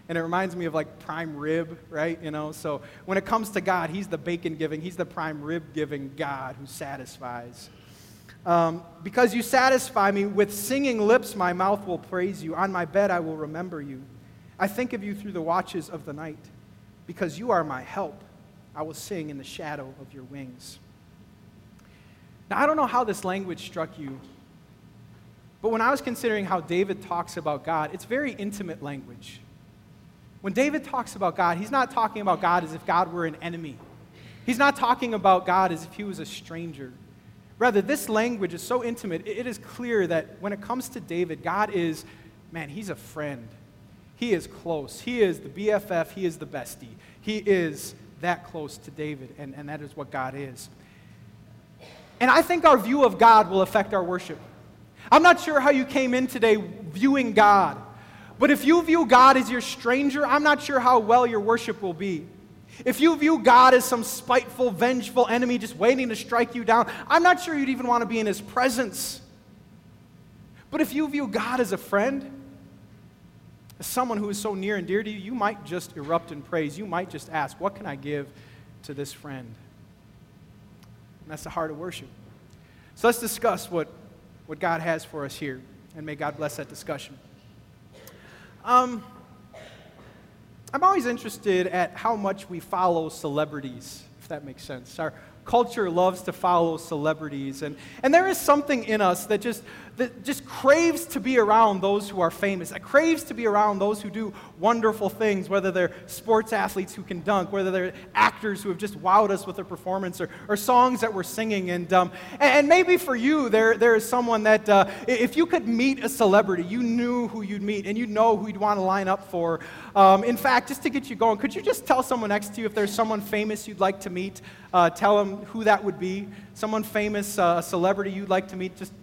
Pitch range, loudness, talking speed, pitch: 165-235 Hz, -24 LUFS, 205 wpm, 195 Hz